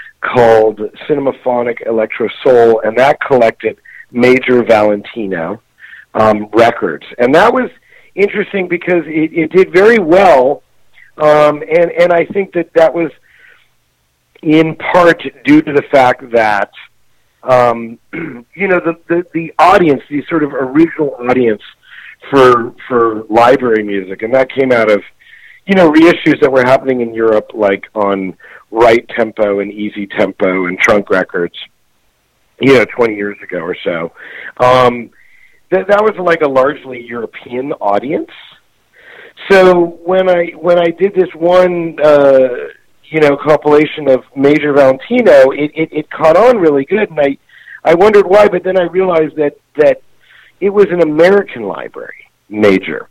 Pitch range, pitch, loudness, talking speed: 115-170 Hz, 145 Hz, -11 LUFS, 145 wpm